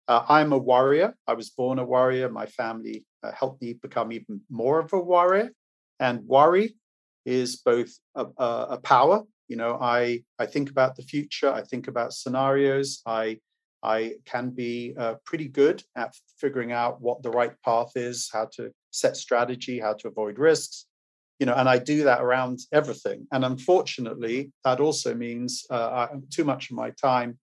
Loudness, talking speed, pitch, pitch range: -25 LUFS, 185 wpm, 125 Hz, 120-140 Hz